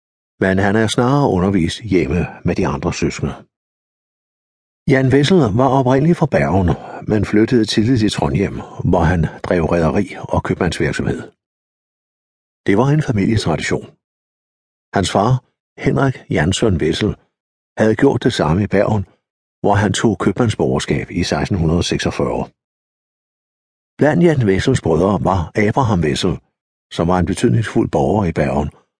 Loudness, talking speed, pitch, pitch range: -16 LUFS, 130 wpm, 110 Hz, 95-130 Hz